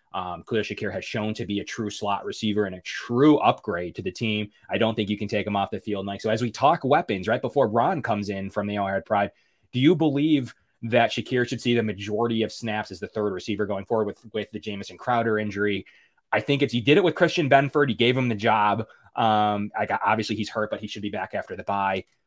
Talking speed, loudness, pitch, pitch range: 250 wpm, -25 LUFS, 105 Hz, 105-115 Hz